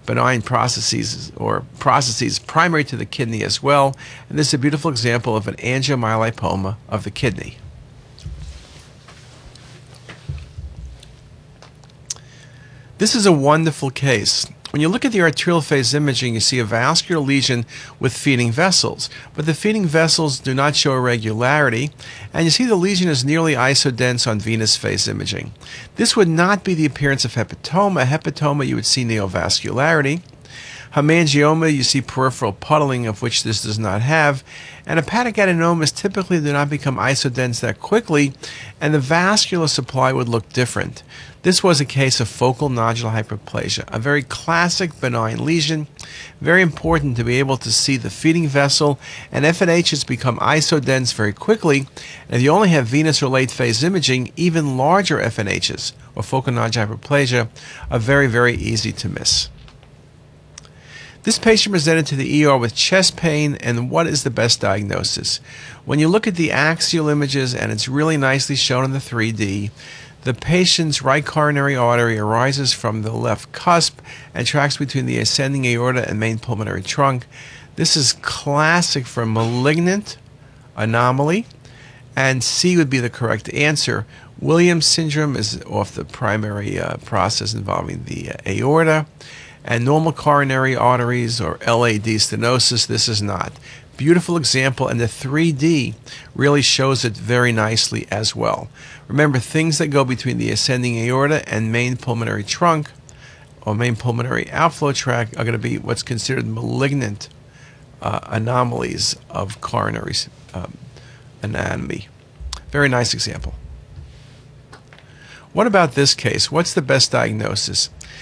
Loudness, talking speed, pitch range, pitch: -17 LUFS, 150 wpm, 120-150 Hz, 135 Hz